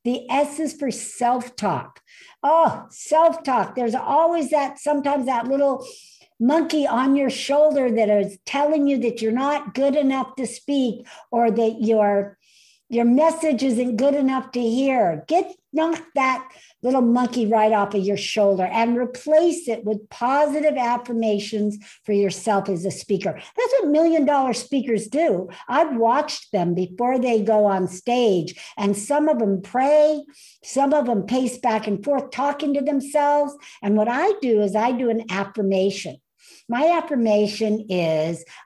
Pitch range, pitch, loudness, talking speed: 215-295 Hz, 250 Hz, -21 LUFS, 155 wpm